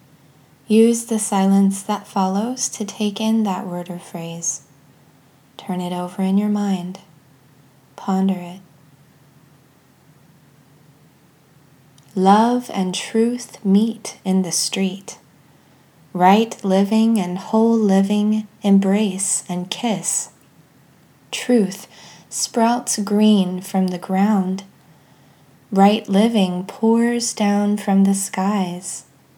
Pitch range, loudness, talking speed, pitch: 155-210 Hz, -19 LUFS, 100 wpm, 190 Hz